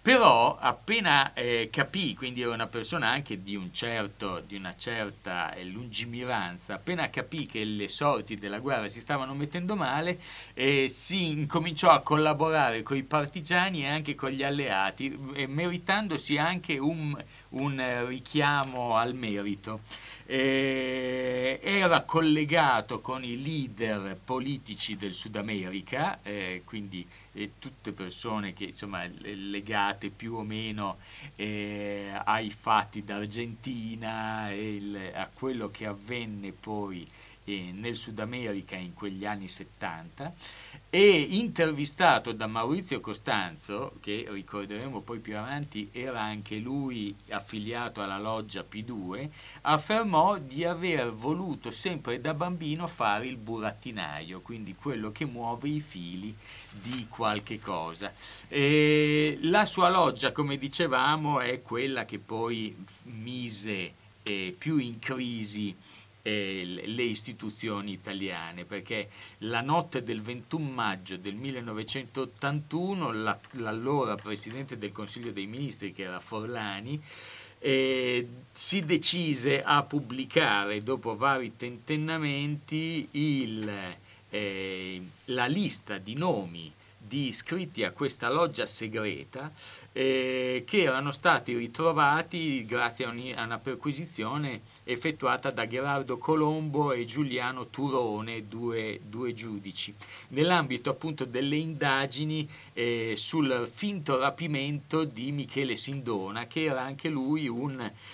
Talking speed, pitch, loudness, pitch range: 115 wpm, 120 Hz, -30 LUFS, 105-145 Hz